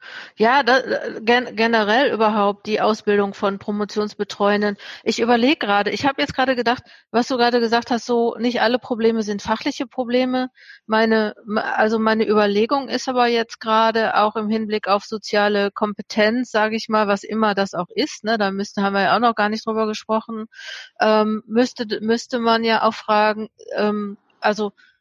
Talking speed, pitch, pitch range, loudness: 175 wpm, 220 Hz, 210-240 Hz, -19 LUFS